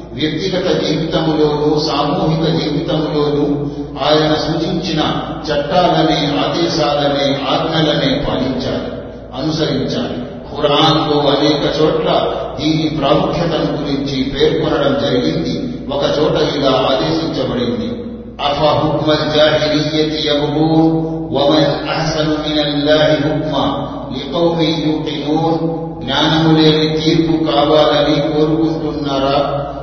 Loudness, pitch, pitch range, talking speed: -15 LUFS, 150 Hz, 145-155 Hz, 50 wpm